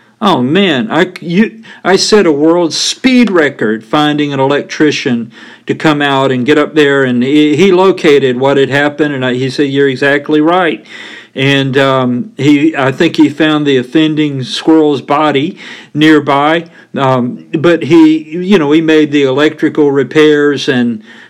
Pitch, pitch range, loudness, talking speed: 150 Hz, 140-160 Hz, -10 LUFS, 160 wpm